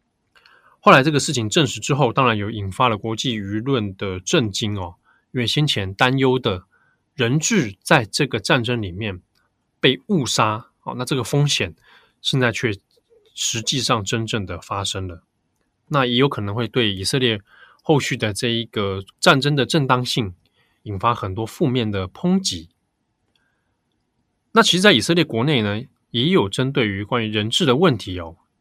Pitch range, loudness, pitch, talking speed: 100-140 Hz, -20 LUFS, 120 Hz, 240 characters per minute